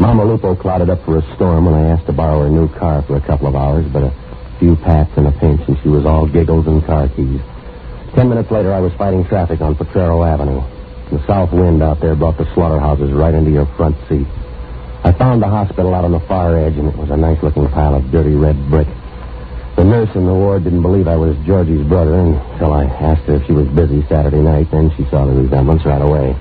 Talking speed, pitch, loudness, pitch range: 240 wpm, 80 Hz, -13 LUFS, 70-85 Hz